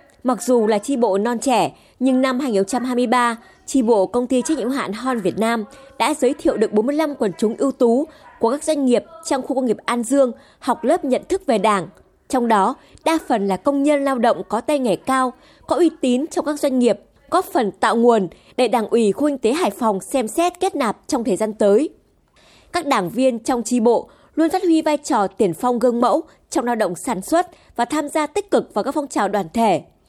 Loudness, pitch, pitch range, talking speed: -19 LUFS, 255 Hz, 230-290 Hz, 230 wpm